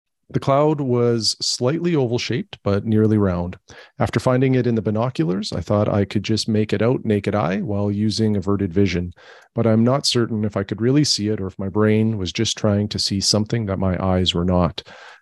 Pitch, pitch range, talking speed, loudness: 110 Hz, 100-120 Hz, 215 wpm, -20 LUFS